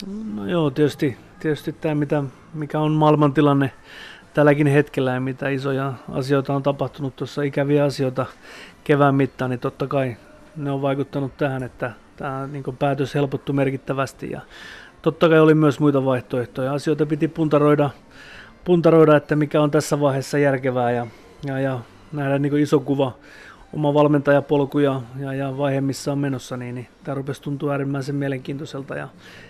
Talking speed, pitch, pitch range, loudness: 155 wpm, 140 Hz, 135-150 Hz, -21 LUFS